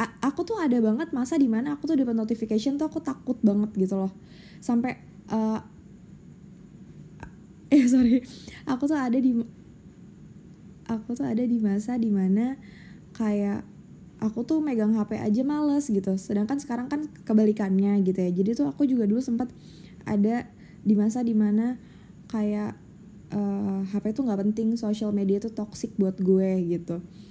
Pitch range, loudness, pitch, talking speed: 195-250 Hz, -26 LUFS, 220 Hz, 150 wpm